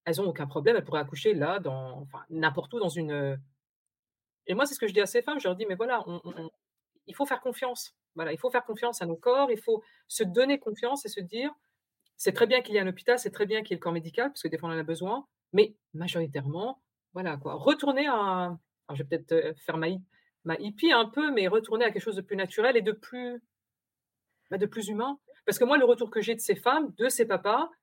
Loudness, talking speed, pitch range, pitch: -29 LUFS, 265 wpm, 170-250 Hz, 215 Hz